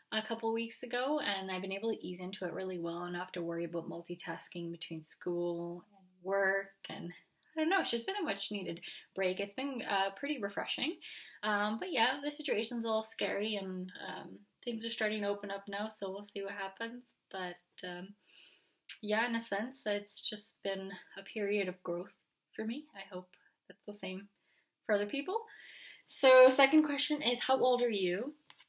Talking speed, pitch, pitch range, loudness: 195 wpm, 205 Hz, 185-235 Hz, -35 LUFS